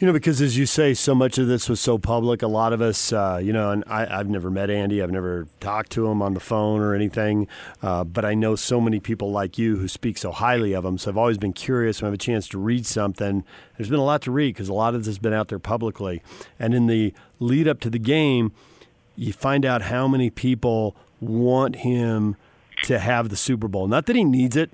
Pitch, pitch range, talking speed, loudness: 115 Hz, 100-125 Hz, 255 wpm, -22 LUFS